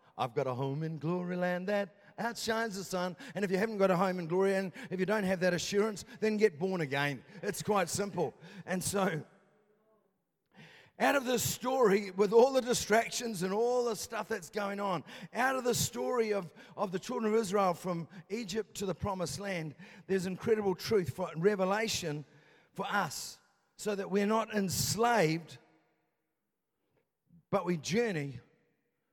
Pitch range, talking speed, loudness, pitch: 175-215 Hz, 170 wpm, -33 LUFS, 195 Hz